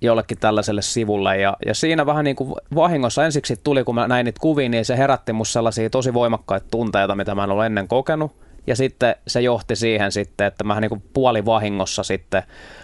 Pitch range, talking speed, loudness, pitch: 105-130 Hz, 200 wpm, -20 LUFS, 115 Hz